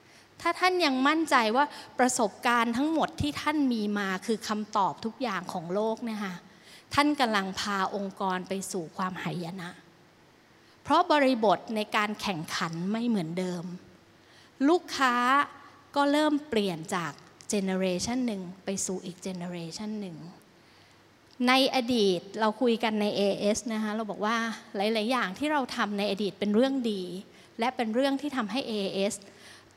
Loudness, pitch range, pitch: -28 LUFS, 190-250 Hz, 215 Hz